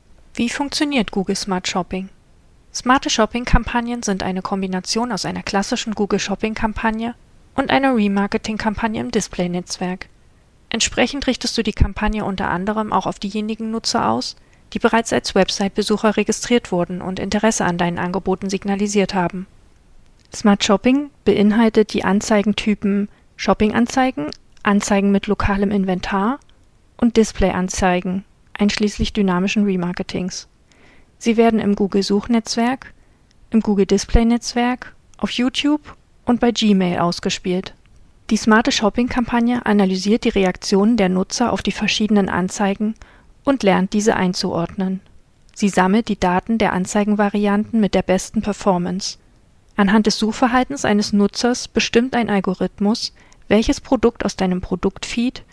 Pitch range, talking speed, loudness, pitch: 195-230 Hz, 120 wpm, -19 LUFS, 210 Hz